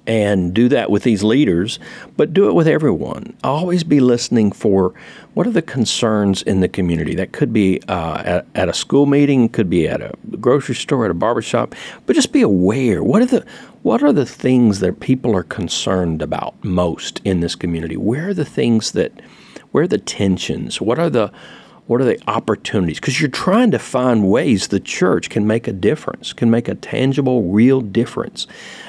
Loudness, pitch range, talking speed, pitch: -17 LUFS, 95-130 Hz, 195 wpm, 110 Hz